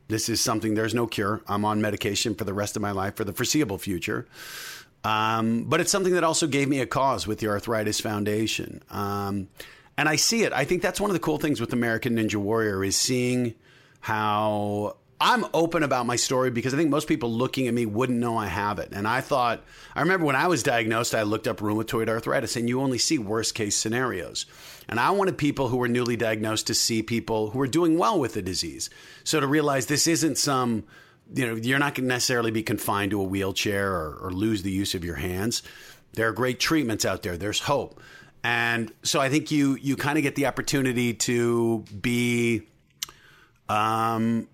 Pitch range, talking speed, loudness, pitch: 110-135 Hz, 215 wpm, -25 LUFS, 115 Hz